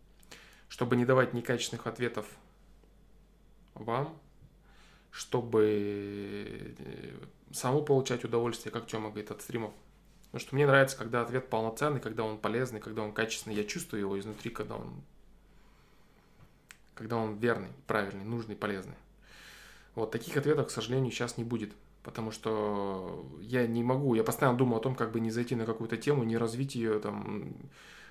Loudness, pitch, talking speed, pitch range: -33 LUFS, 115 Hz, 145 wpm, 105-125 Hz